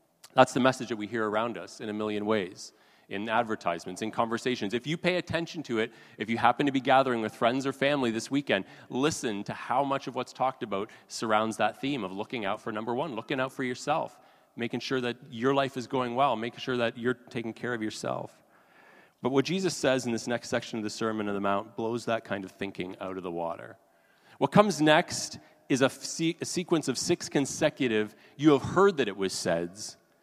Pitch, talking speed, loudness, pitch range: 125 Hz, 220 wpm, -29 LUFS, 110-135 Hz